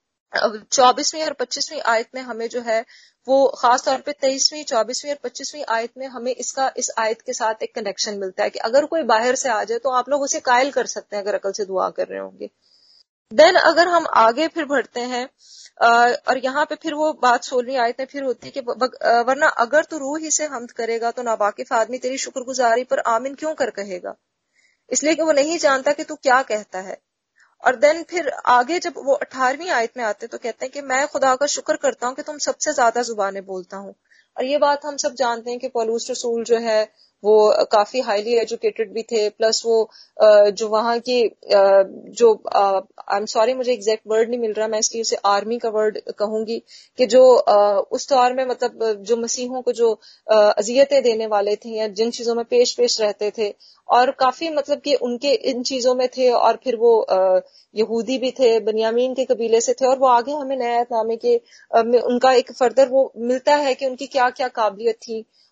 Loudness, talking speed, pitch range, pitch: -19 LUFS, 210 wpm, 225-275 Hz, 245 Hz